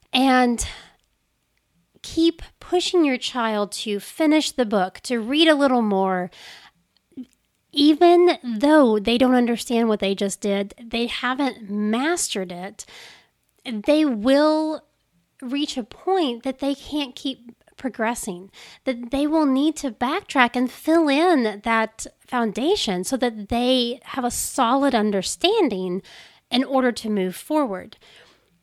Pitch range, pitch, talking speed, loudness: 220-295 Hz, 250 Hz, 125 wpm, -21 LUFS